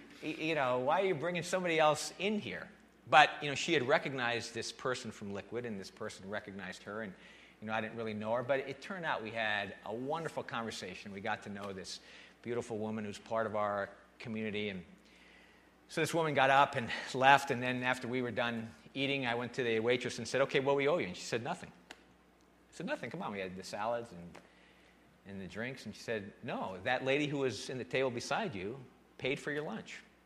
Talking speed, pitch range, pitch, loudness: 230 wpm, 105-135 Hz, 115 Hz, -35 LUFS